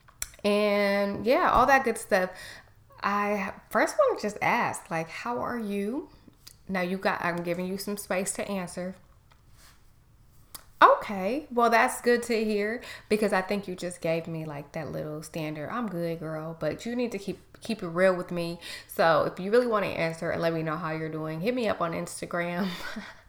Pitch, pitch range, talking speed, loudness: 190 Hz, 165-210 Hz, 195 wpm, -28 LUFS